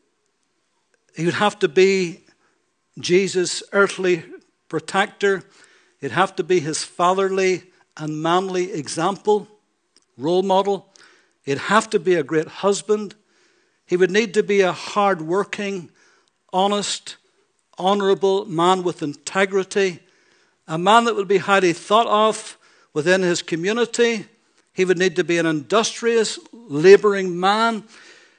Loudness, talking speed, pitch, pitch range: -20 LUFS, 125 wpm, 195 Hz, 180-205 Hz